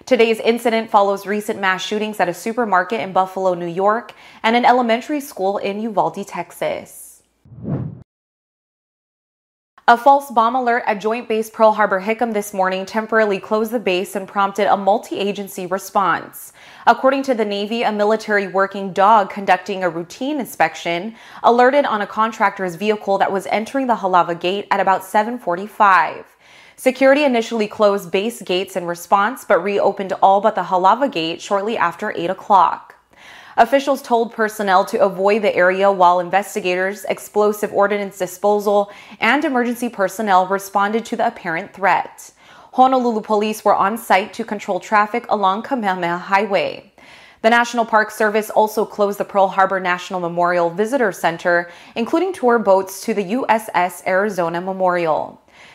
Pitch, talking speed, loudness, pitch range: 205 Hz, 145 wpm, -18 LUFS, 190-225 Hz